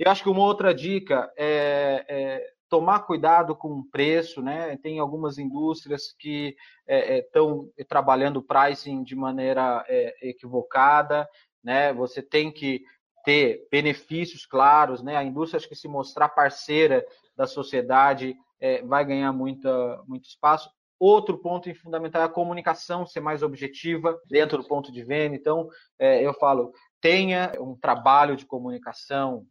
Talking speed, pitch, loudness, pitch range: 150 wpm, 150 Hz, -24 LUFS, 135-170 Hz